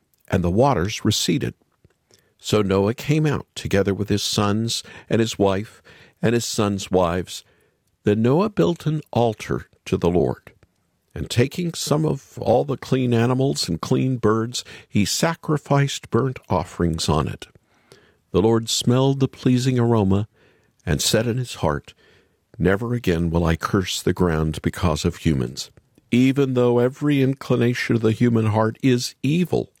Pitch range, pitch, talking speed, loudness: 95-130 Hz, 115 Hz, 150 wpm, -21 LUFS